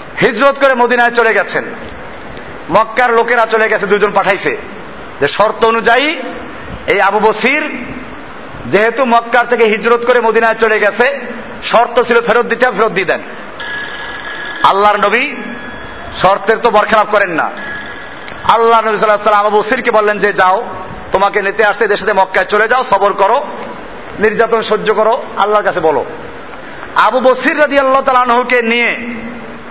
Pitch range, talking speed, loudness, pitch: 210-245 Hz, 125 wpm, -11 LUFS, 225 Hz